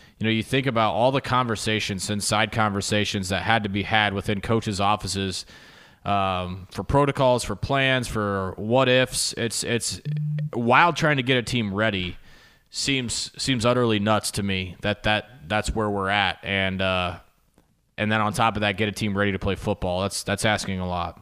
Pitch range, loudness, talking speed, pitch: 100-120 Hz, -23 LUFS, 190 wpm, 105 Hz